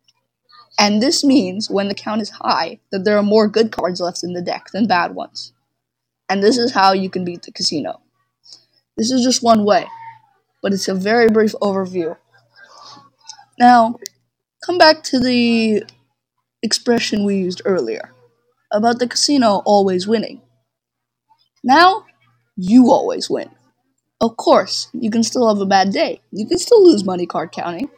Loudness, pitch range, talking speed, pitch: -16 LUFS, 195-260 Hz, 160 wpm, 225 Hz